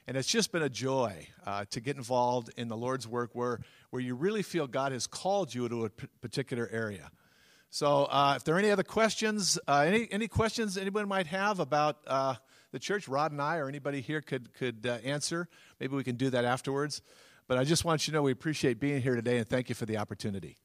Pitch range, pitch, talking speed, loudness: 120-165 Hz, 135 Hz, 230 wpm, -32 LUFS